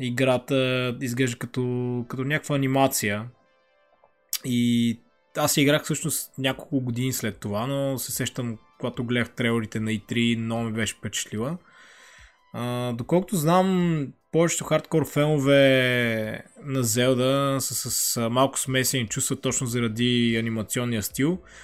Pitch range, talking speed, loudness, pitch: 115-135 Hz, 120 wpm, -24 LUFS, 125 Hz